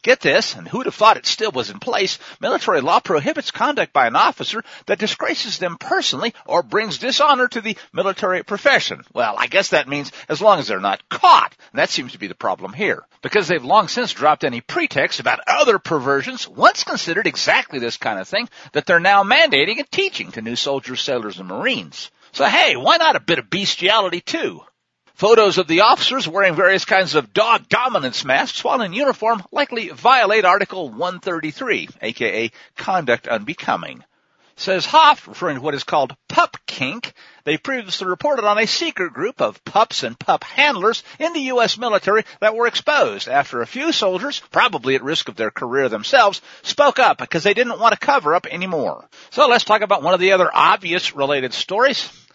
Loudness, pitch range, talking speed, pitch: -17 LUFS, 180-265 Hz, 190 wpm, 205 Hz